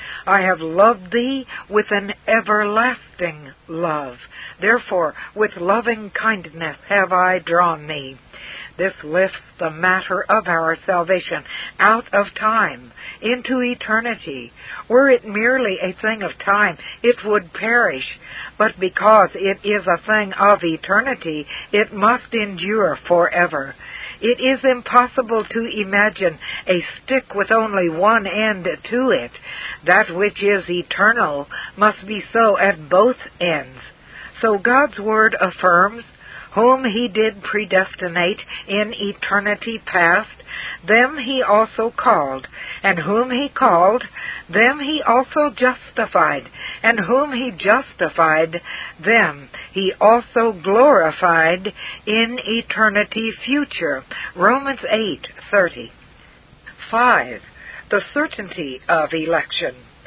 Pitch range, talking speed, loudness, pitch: 180-230 Hz, 115 wpm, -17 LUFS, 210 Hz